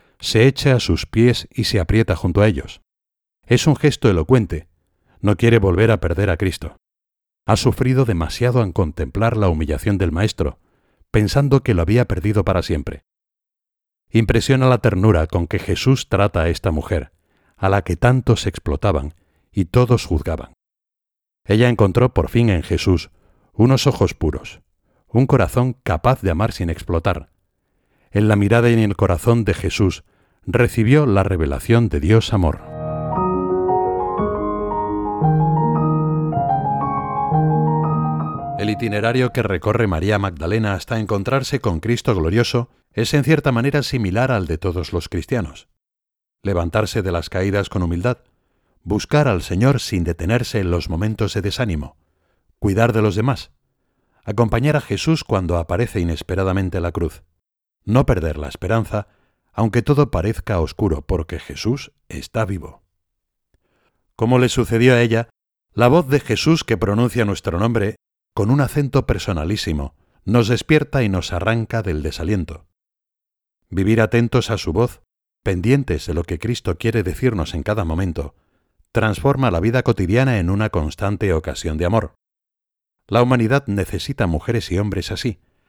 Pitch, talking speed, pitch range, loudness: 100 Hz, 145 wpm, 85-120 Hz, -19 LUFS